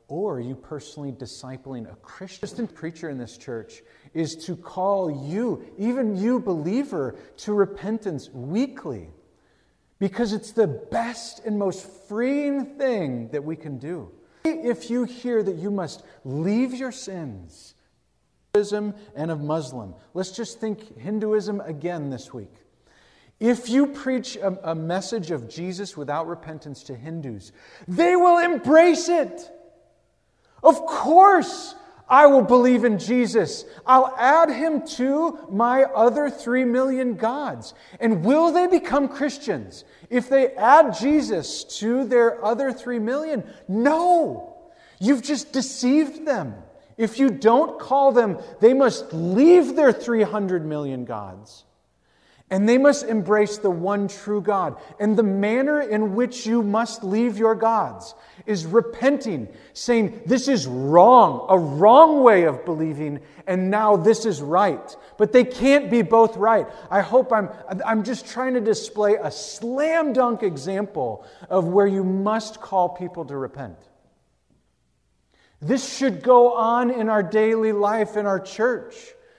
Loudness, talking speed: -20 LUFS, 145 wpm